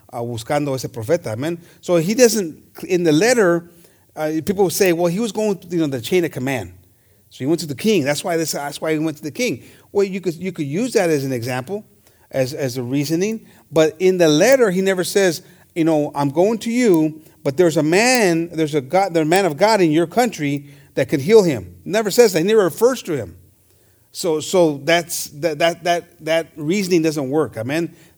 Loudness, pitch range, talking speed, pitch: -18 LUFS, 145-185 Hz, 230 wpm, 165 Hz